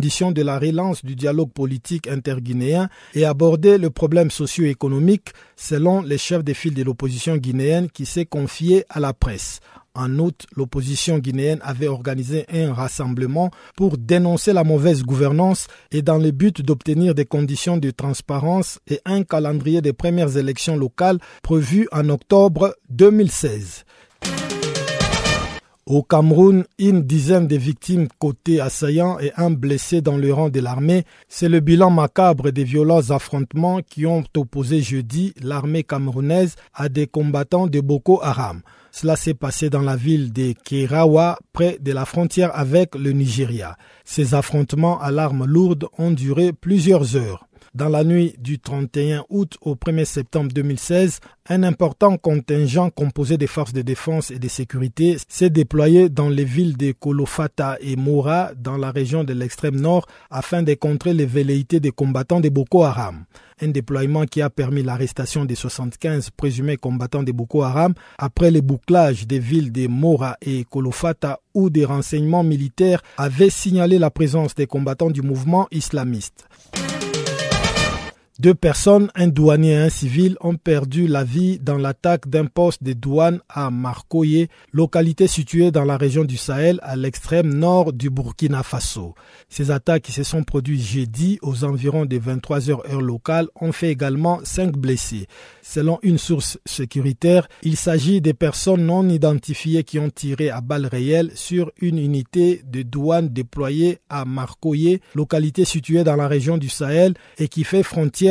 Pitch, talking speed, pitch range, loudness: 150 Hz, 160 wpm, 140-170 Hz, -19 LUFS